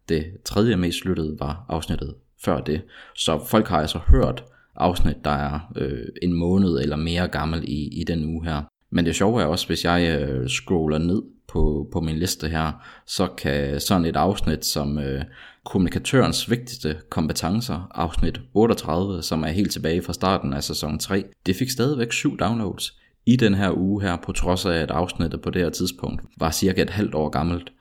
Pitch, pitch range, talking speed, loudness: 85 Hz, 75-95 Hz, 190 wpm, -23 LUFS